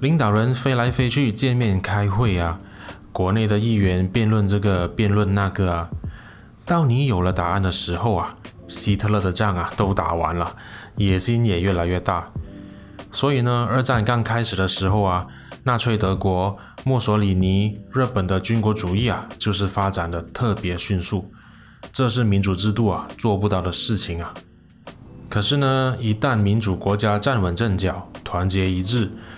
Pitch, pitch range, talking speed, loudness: 100 Hz, 95-115 Hz, 245 characters per minute, -21 LUFS